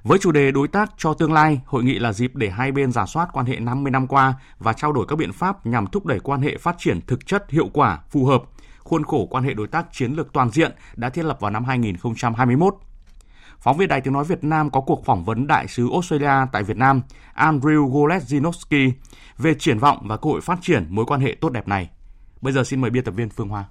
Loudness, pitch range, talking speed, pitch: -20 LUFS, 120-155 Hz, 250 wpm, 135 Hz